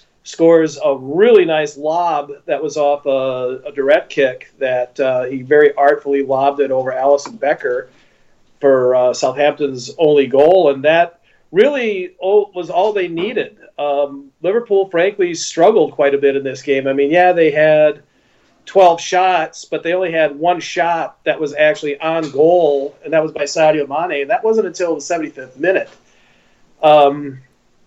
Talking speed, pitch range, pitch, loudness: 165 wpm, 140-175 Hz, 150 Hz, -15 LUFS